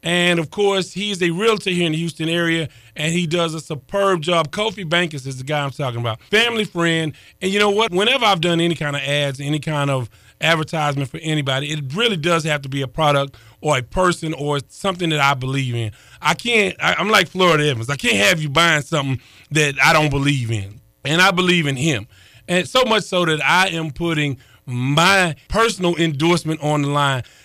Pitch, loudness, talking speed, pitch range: 160 Hz, -18 LUFS, 215 wpm, 140-175 Hz